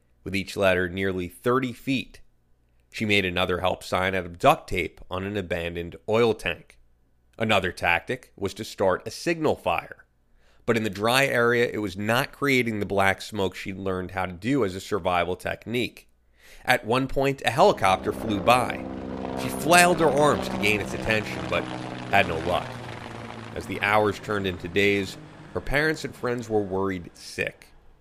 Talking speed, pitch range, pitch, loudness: 175 wpm, 85-120 Hz, 95 Hz, -25 LUFS